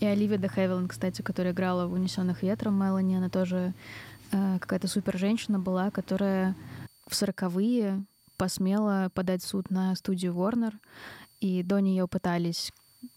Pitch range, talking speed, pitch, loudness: 185-200 Hz, 135 wpm, 190 Hz, -29 LUFS